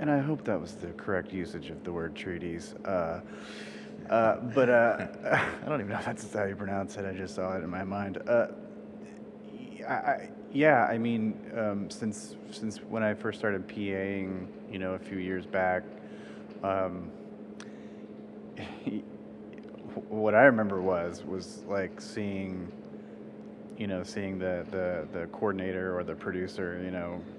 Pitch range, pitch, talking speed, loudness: 90-105 Hz, 95 Hz, 160 wpm, -31 LUFS